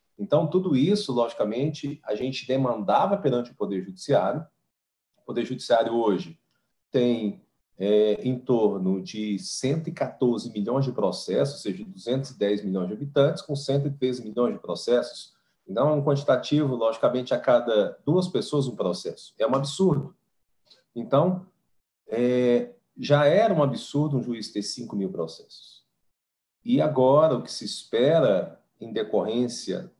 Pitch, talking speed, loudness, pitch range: 130 Hz, 140 wpm, -25 LUFS, 115-145 Hz